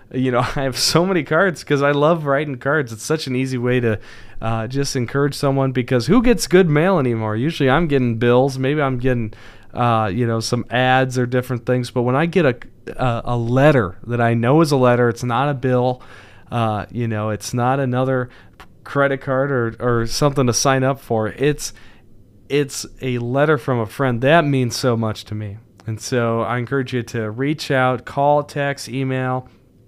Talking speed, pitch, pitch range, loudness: 200 wpm, 125 Hz, 115-140 Hz, -18 LUFS